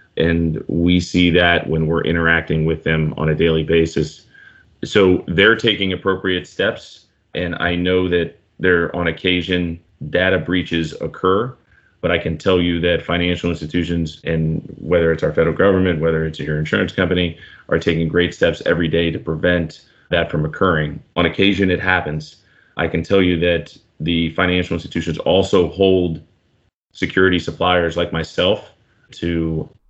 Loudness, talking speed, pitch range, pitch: -18 LUFS, 155 wpm, 80-90 Hz, 85 Hz